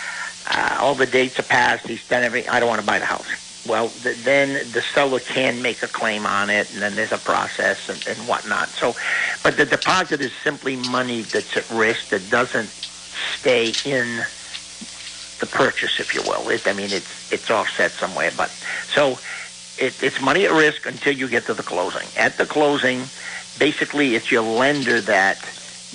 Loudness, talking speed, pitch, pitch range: -20 LUFS, 190 wpm, 125 Hz, 100-135 Hz